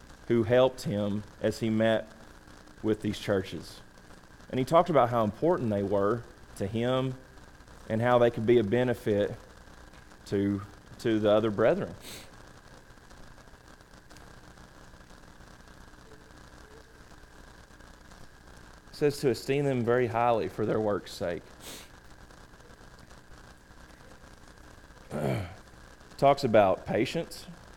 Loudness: -28 LUFS